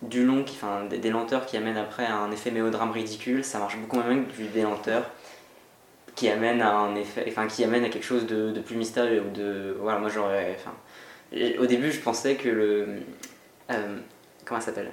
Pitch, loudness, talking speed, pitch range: 110 Hz, -27 LUFS, 215 wpm, 105-120 Hz